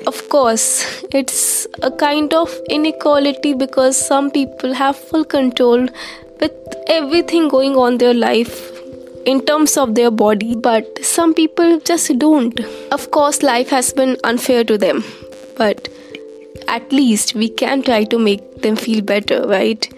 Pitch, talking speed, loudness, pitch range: 260 Hz, 145 wpm, -15 LUFS, 230-295 Hz